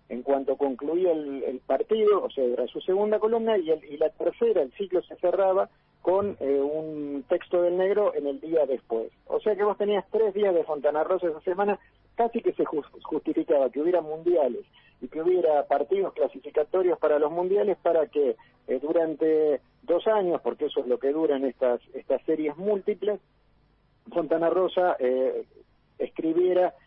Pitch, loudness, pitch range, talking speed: 175 Hz, -26 LUFS, 155-210 Hz, 175 wpm